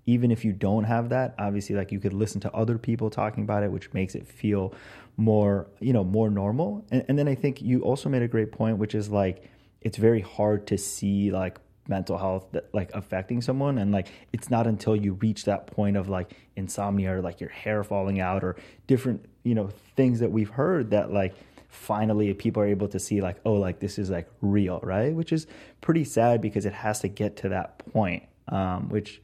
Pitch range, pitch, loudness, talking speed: 100-115 Hz, 105 Hz, -27 LUFS, 220 wpm